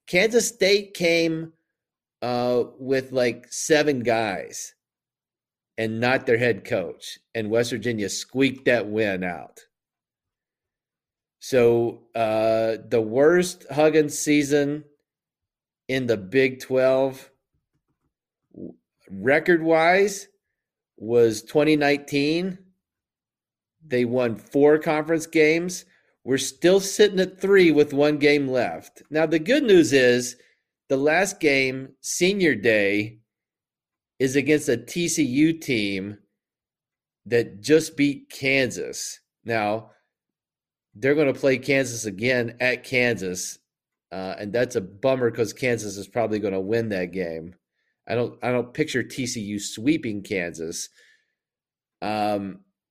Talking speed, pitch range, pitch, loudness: 110 wpm, 115-155 Hz, 130 Hz, -22 LUFS